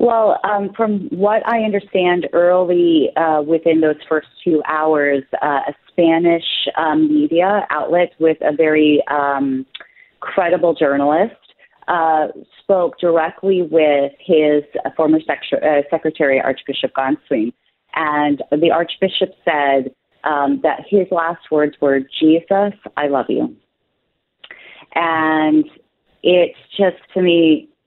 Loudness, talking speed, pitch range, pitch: -16 LUFS, 120 wpm, 150-180 Hz, 160 Hz